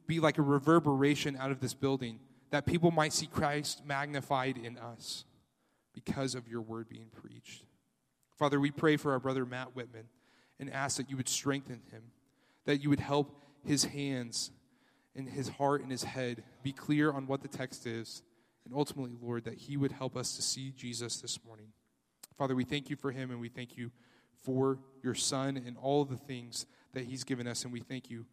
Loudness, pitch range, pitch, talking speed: -35 LUFS, 120-140 Hz, 135 Hz, 200 wpm